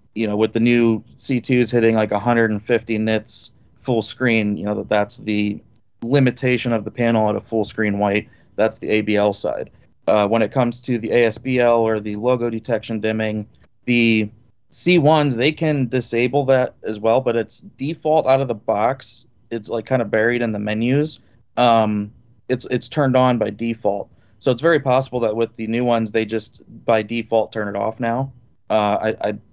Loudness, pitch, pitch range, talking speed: -19 LUFS, 115 Hz, 110-125 Hz, 185 wpm